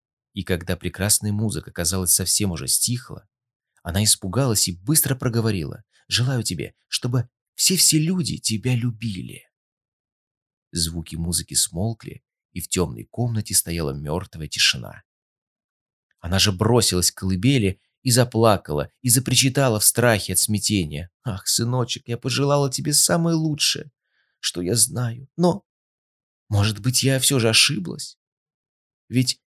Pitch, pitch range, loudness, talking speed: 115 Hz, 95-130 Hz, -20 LUFS, 125 wpm